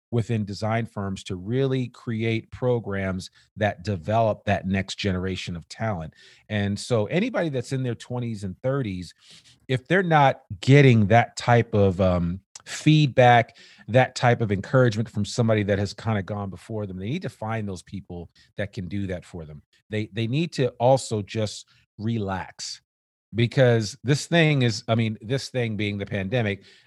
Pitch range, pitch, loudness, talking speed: 100-125 Hz, 110 Hz, -24 LUFS, 170 wpm